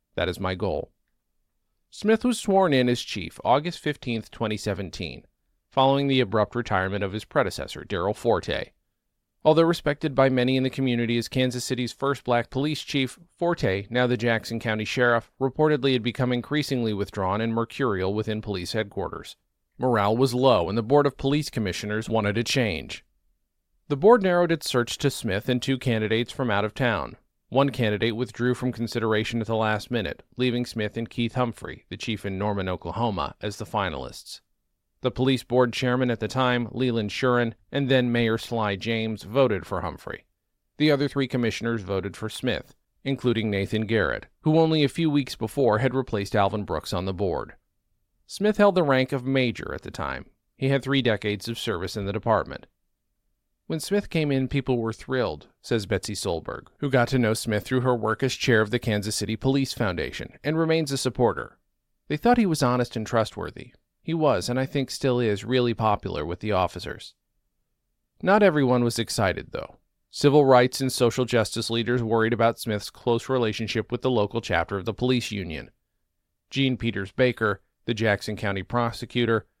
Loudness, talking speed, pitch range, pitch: -25 LUFS, 180 wpm, 110-130 Hz, 120 Hz